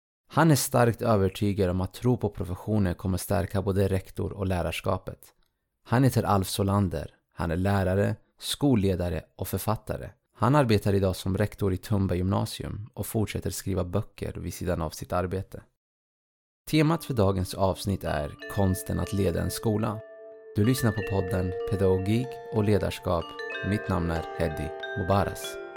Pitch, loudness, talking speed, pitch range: 100 Hz, -27 LUFS, 150 wpm, 95-110 Hz